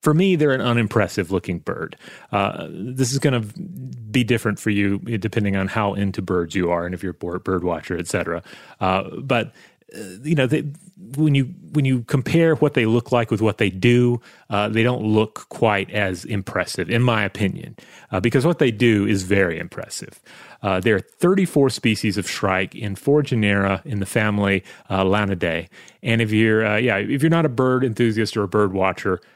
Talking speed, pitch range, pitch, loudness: 200 wpm, 100-130 Hz, 110 Hz, -20 LUFS